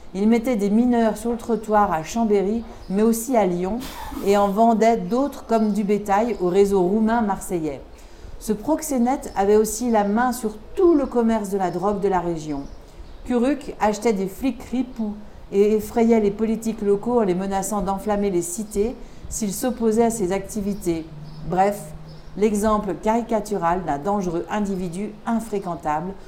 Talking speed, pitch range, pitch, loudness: 155 wpm, 195-230 Hz, 210 Hz, -22 LUFS